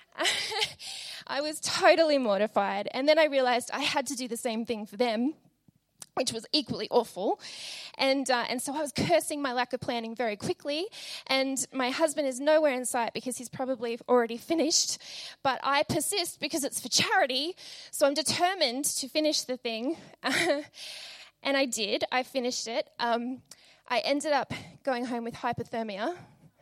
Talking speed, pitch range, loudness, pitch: 165 wpm, 240-305 Hz, -29 LUFS, 265 Hz